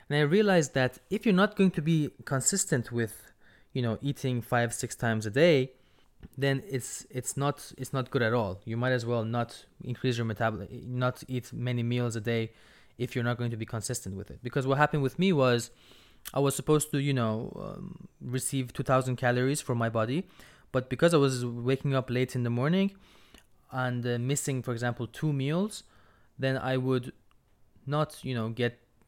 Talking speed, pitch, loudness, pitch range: 200 wpm, 130 Hz, -29 LUFS, 120-140 Hz